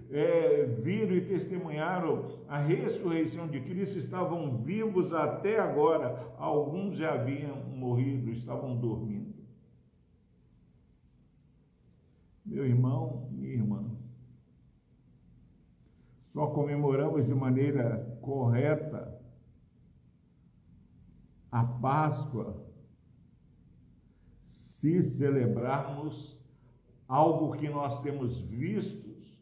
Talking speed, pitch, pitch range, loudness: 75 wpm, 135 Hz, 120-155 Hz, -31 LUFS